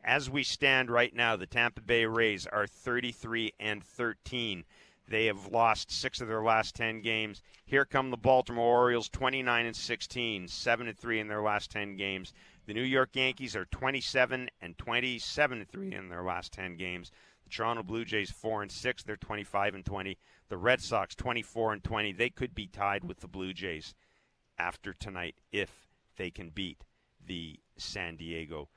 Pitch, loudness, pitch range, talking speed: 110 Hz, -32 LUFS, 95-120 Hz, 175 wpm